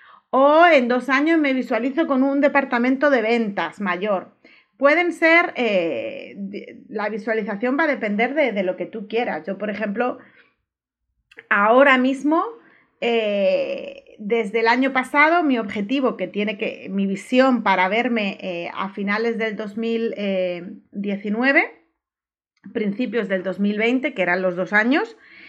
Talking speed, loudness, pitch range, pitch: 135 wpm, -20 LUFS, 205-275 Hz, 230 Hz